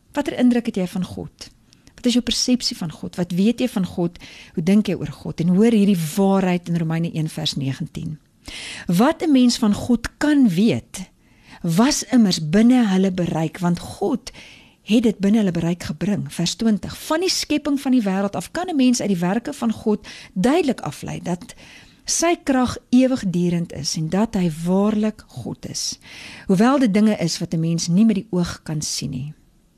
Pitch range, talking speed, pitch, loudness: 175-240 Hz, 185 wpm, 195 Hz, -20 LUFS